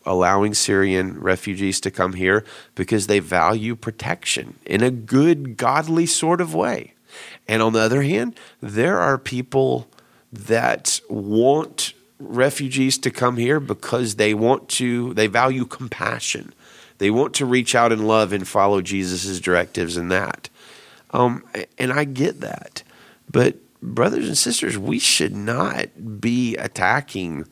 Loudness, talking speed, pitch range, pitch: -20 LUFS, 140 wpm, 95-125 Hz, 110 Hz